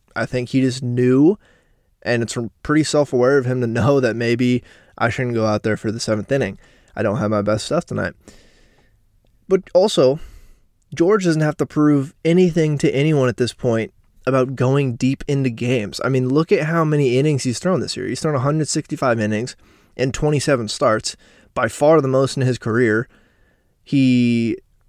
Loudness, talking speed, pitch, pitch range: -19 LUFS, 185 wpm, 130 Hz, 115-145 Hz